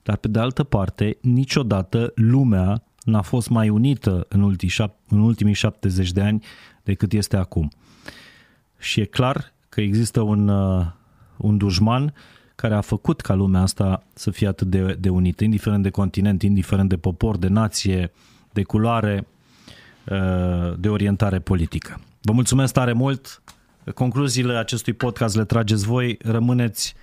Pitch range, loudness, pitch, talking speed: 100-115 Hz, -21 LUFS, 105 Hz, 140 wpm